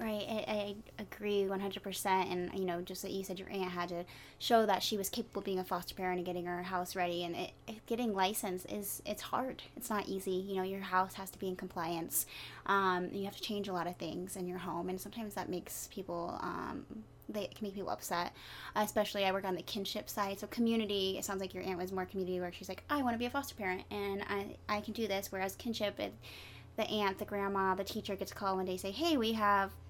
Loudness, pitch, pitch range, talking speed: -37 LUFS, 195 Hz, 185-205 Hz, 250 wpm